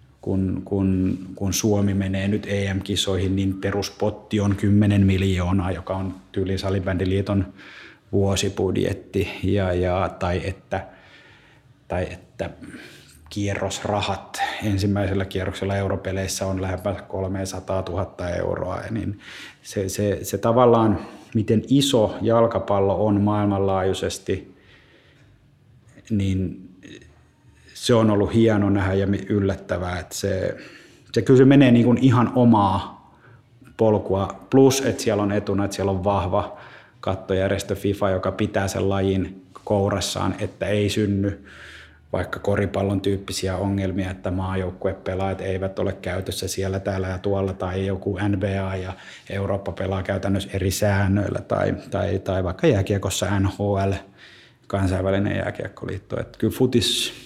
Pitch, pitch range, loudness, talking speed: 100 Hz, 95-105 Hz, -23 LUFS, 115 wpm